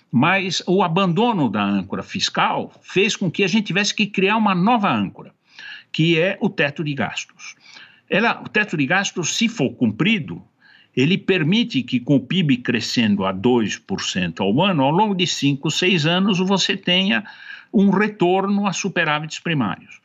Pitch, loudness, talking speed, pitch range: 190 Hz, -19 LUFS, 165 wpm, 160-205 Hz